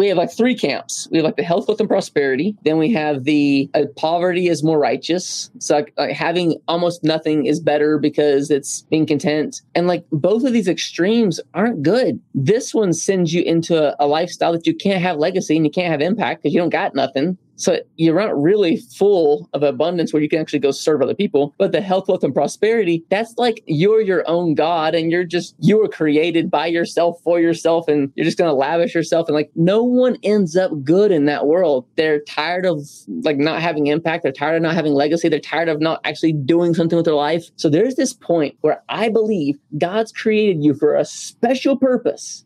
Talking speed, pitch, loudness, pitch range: 220 wpm, 165 Hz, -18 LUFS, 150-185 Hz